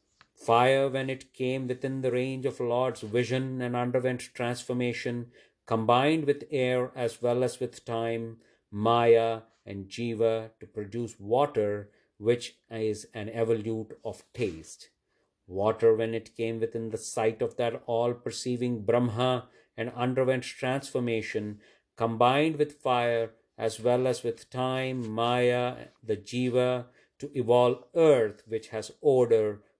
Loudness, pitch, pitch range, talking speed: -28 LUFS, 120 Hz, 115-125 Hz, 130 wpm